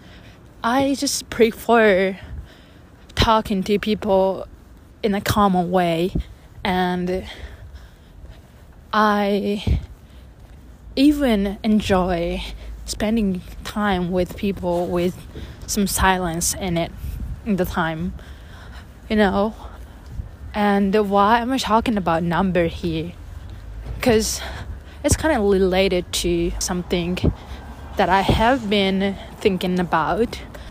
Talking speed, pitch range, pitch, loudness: 95 wpm, 170-210 Hz, 190 Hz, -20 LUFS